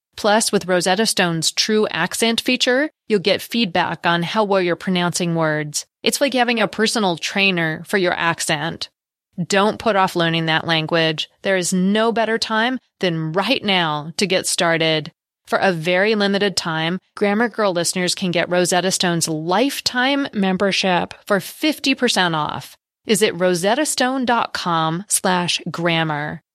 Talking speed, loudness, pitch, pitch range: 145 wpm, -18 LUFS, 185 Hz, 170-220 Hz